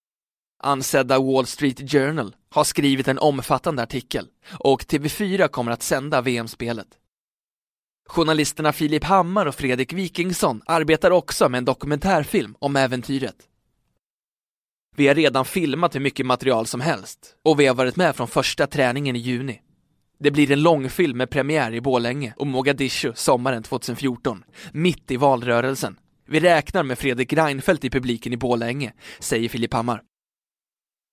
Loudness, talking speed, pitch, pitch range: -21 LUFS, 145 wpm, 135 Hz, 125-150 Hz